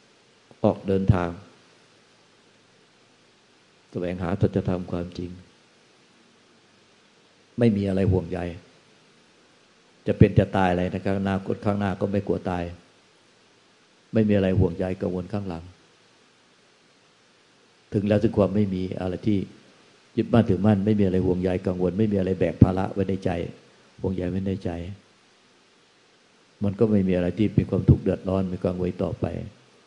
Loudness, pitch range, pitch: -24 LUFS, 90-100 Hz, 95 Hz